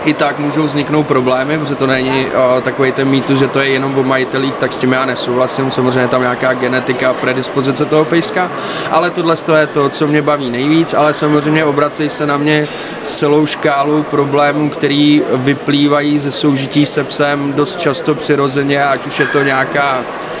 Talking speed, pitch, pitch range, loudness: 185 wpm, 145 Hz, 135-150 Hz, -12 LUFS